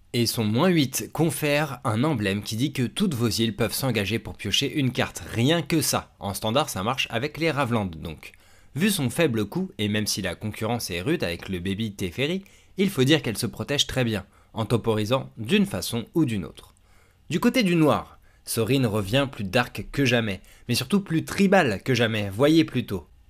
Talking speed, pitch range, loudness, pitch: 200 wpm, 100-145 Hz, -24 LUFS, 115 Hz